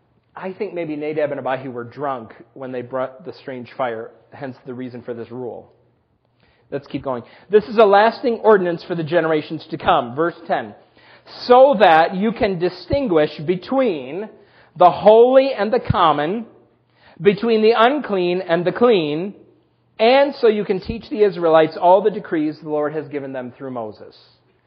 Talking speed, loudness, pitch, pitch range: 170 wpm, -17 LUFS, 170 Hz, 140-210 Hz